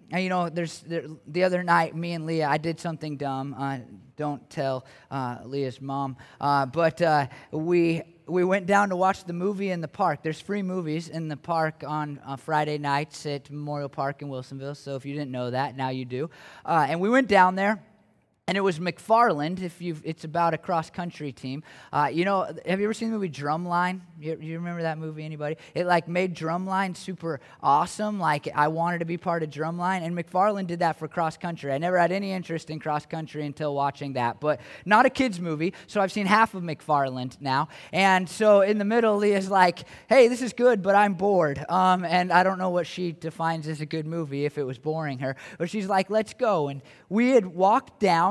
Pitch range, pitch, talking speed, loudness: 150-185 Hz, 165 Hz, 220 wpm, -26 LUFS